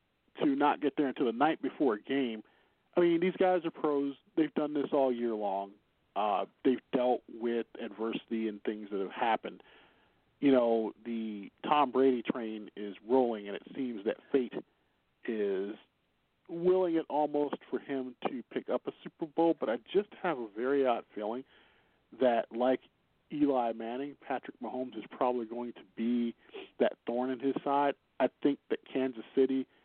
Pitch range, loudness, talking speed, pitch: 115-145 Hz, -33 LUFS, 175 wpm, 130 Hz